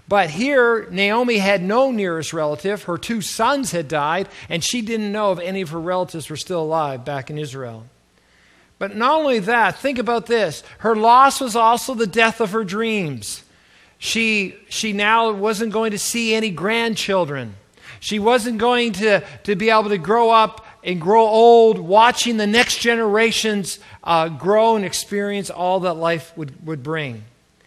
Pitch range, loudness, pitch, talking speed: 170-230 Hz, -18 LUFS, 210 Hz, 170 wpm